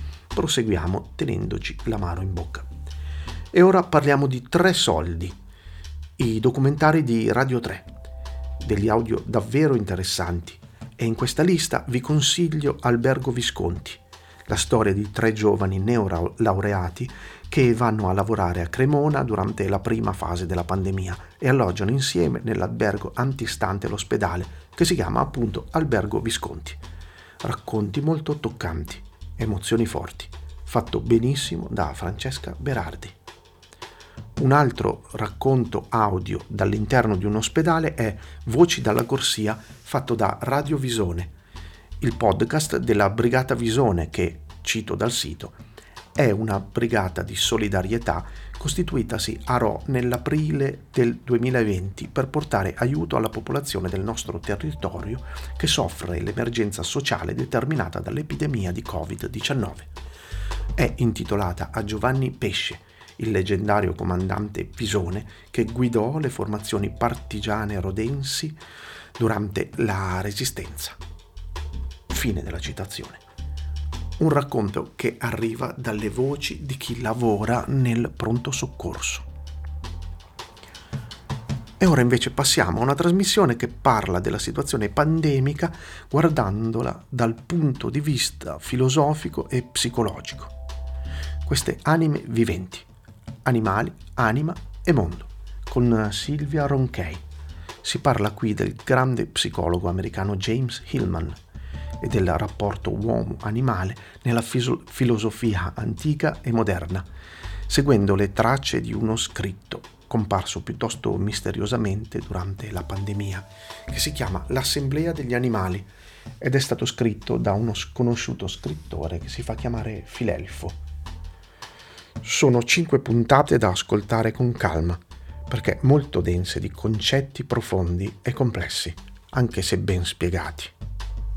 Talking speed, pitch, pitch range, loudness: 115 wpm, 110 Hz, 90-125 Hz, -24 LUFS